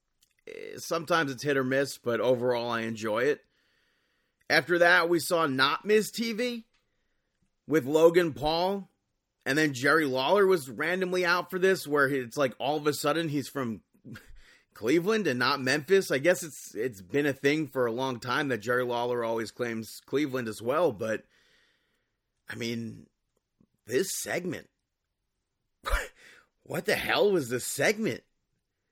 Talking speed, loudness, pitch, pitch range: 150 wpm, -28 LUFS, 145 Hz, 125-180 Hz